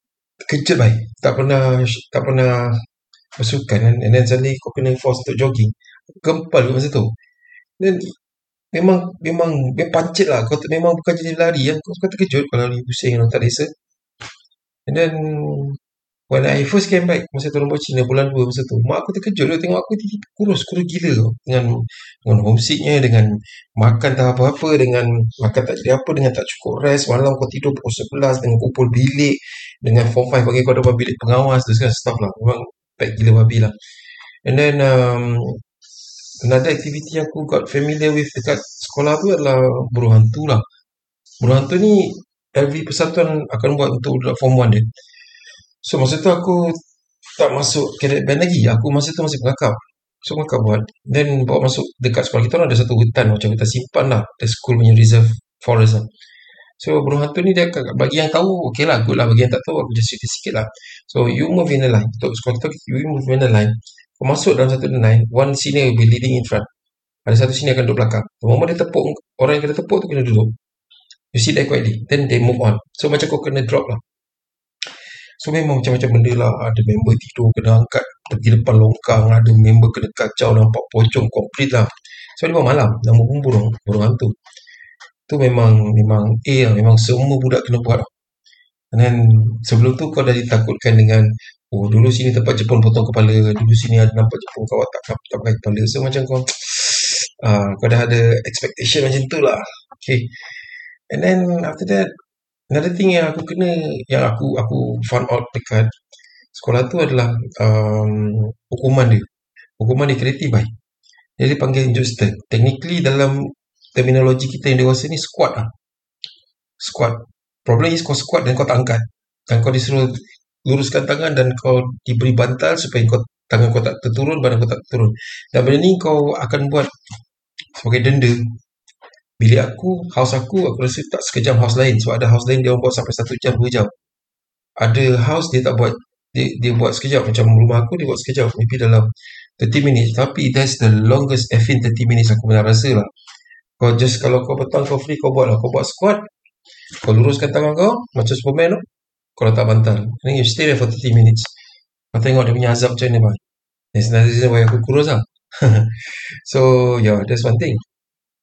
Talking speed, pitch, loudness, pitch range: 190 wpm, 125 Hz, -16 LUFS, 115-145 Hz